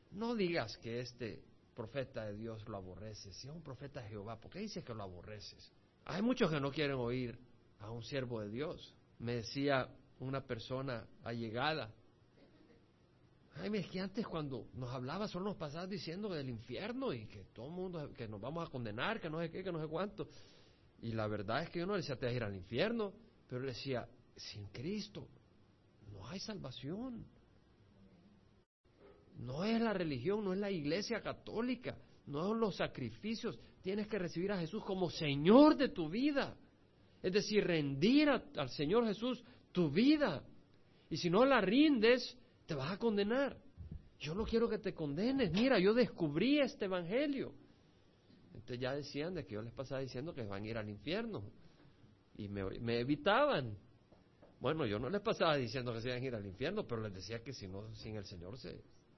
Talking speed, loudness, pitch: 190 wpm, -38 LUFS, 145 Hz